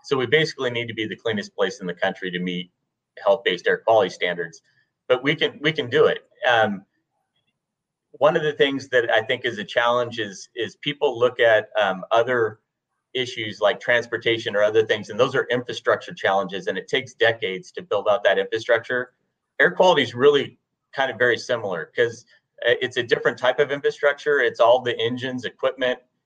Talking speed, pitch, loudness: 190 wpm, 145 Hz, -22 LUFS